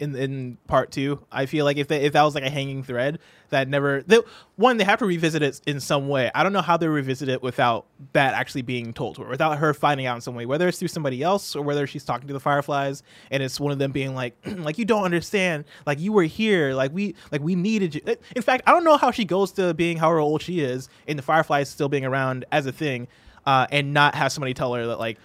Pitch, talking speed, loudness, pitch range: 145 Hz, 270 wpm, -23 LUFS, 135-170 Hz